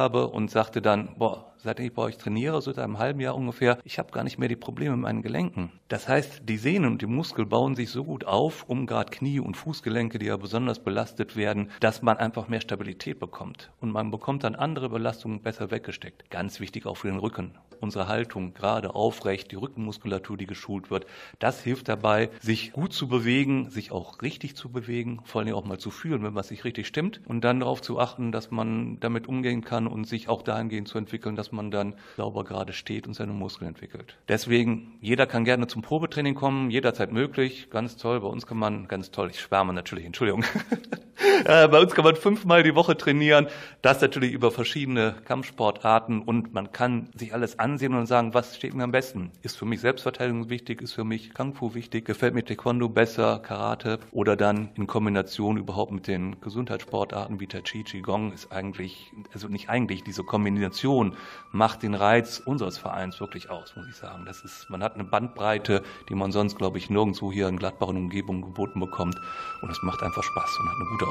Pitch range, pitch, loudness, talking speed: 100-125 Hz, 115 Hz, -27 LUFS, 210 wpm